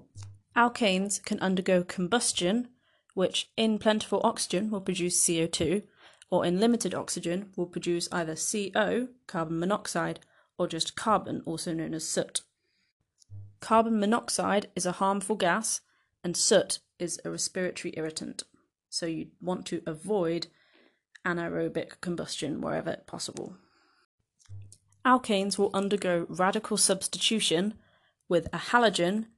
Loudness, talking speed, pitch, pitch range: -29 LUFS, 115 wpm, 185 Hz, 170-210 Hz